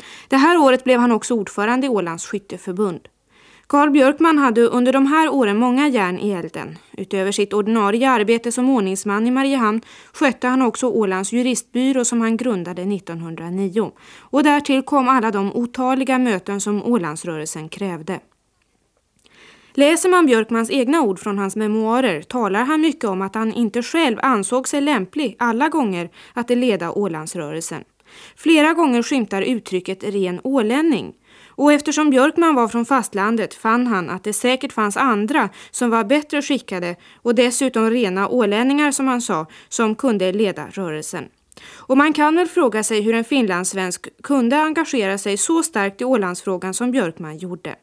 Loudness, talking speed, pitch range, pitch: -18 LUFS, 160 wpm, 200-265 Hz, 235 Hz